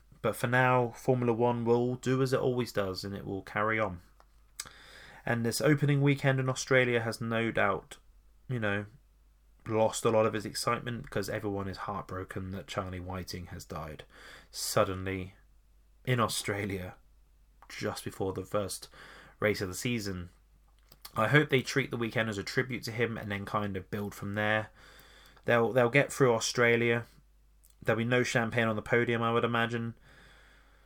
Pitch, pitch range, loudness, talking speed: 110 Hz, 95-120 Hz, -30 LUFS, 165 wpm